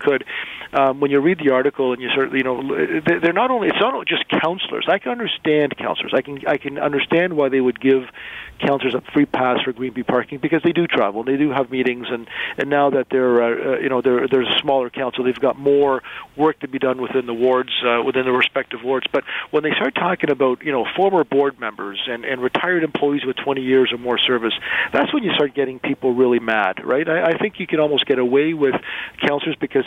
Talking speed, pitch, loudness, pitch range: 235 wpm, 135 Hz, -19 LUFS, 125-145 Hz